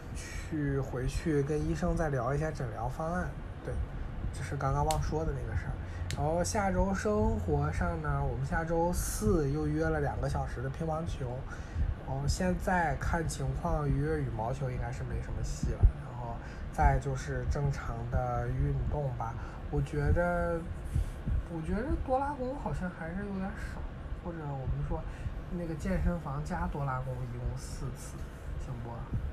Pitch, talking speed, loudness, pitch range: 140 Hz, 235 characters per minute, -34 LUFS, 115-160 Hz